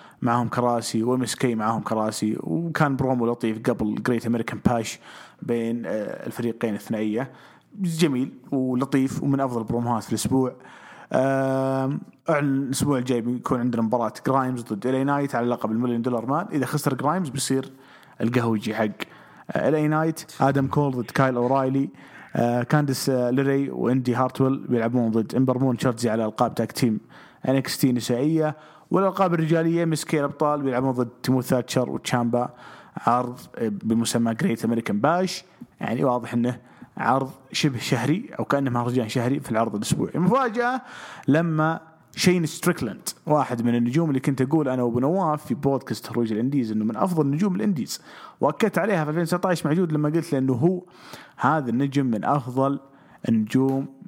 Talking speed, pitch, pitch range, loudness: 140 wpm, 130 Hz, 120-150 Hz, -24 LUFS